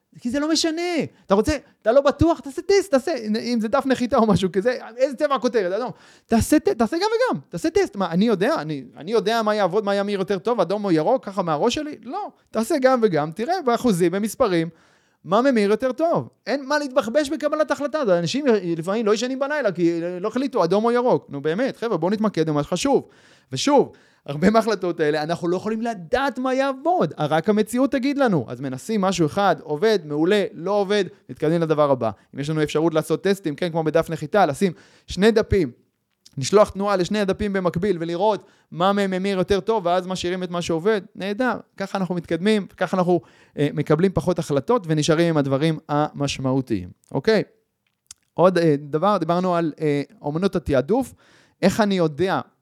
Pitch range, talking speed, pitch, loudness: 165-240 Hz, 190 wpm, 200 Hz, -21 LUFS